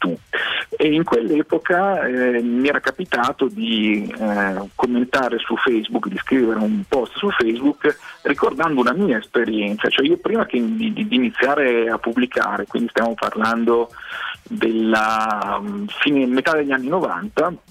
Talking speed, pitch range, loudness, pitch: 130 wpm, 110-150 Hz, -19 LUFS, 125 Hz